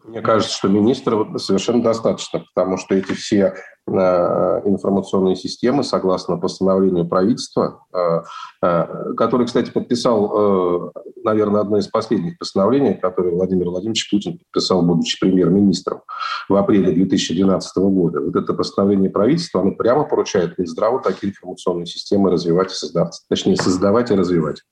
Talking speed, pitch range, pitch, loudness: 125 wpm, 90-100 Hz, 95 Hz, -18 LUFS